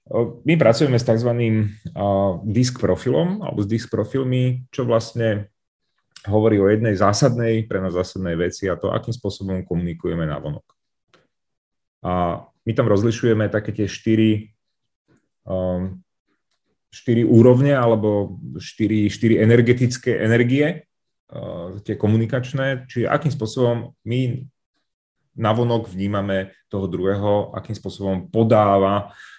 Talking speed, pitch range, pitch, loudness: 115 wpm, 100-120 Hz, 110 Hz, -20 LUFS